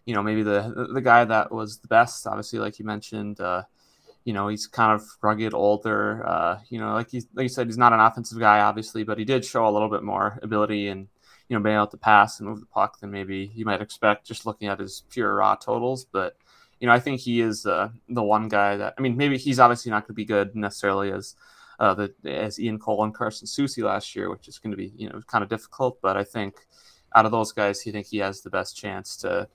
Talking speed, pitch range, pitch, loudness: 260 wpm, 105-115 Hz, 110 Hz, -24 LUFS